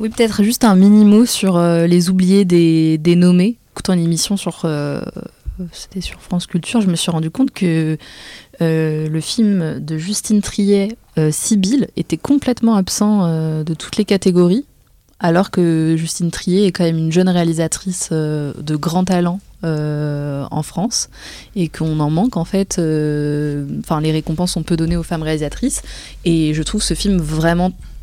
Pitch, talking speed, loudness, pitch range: 175 Hz, 175 wpm, -16 LUFS, 160-195 Hz